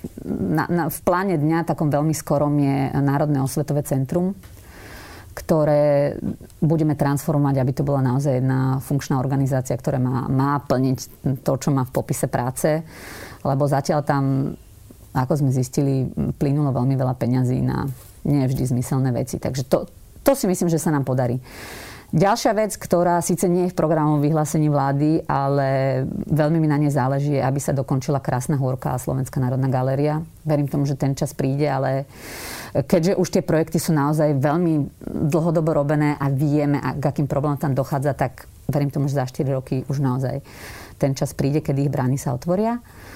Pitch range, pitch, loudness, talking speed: 130-155 Hz, 140 Hz, -21 LUFS, 165 wpm